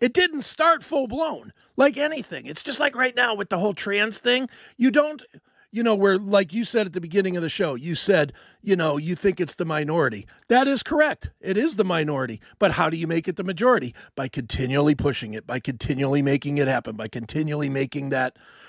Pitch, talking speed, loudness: 190 Hz, 220 wpm, -23 LUFS